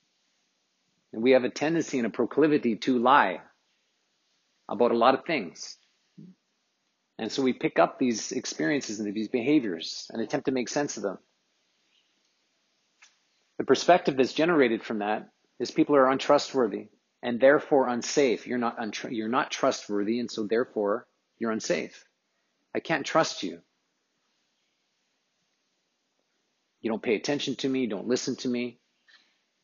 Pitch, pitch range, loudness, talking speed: 130 Hz, 115-145 Hz, -26 LUFS, 145 wpm